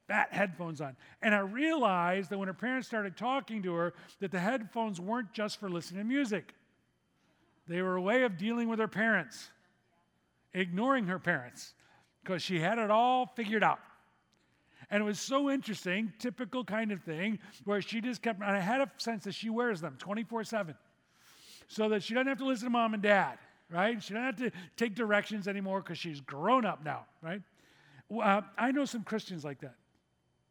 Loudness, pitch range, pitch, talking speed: -33 LUFS, 180-230 Hz, 205 Hz, 195 wpm